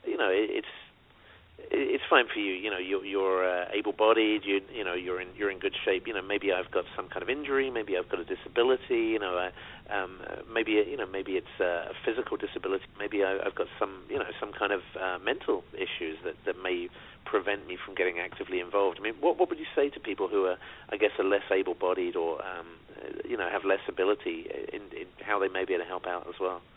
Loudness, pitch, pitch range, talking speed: -30 LUFS, 390 Hz, 320-425 Hz, 240 wpm